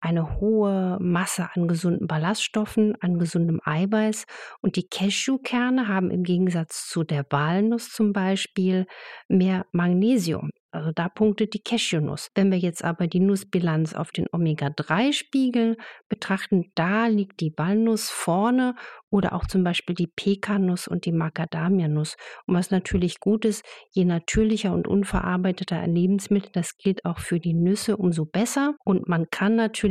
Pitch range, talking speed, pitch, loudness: 170-210 Hz, 150 wpm, 190 Hz, -24 LUFS